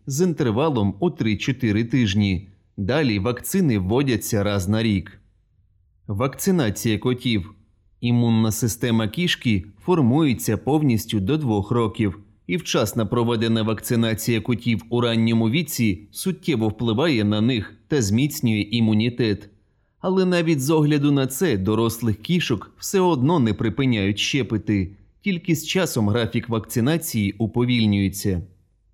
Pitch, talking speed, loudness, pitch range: 115 Hz, 115 wpm, -22 LUFS, 105-135 Hz